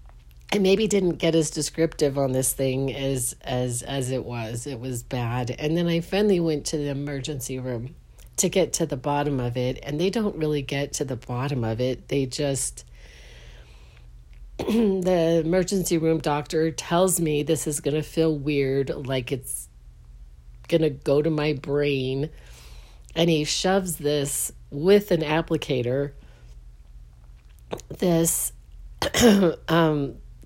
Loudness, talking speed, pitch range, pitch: -24 LUFS, 140 wpm, 125-160 Hz, 140 Hz